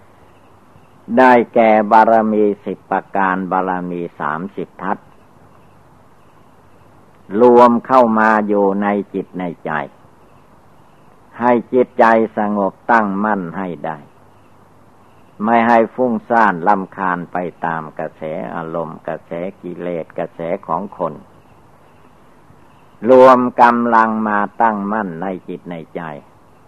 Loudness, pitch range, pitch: -15 LUFS, 90-115 Hz, 105 Hz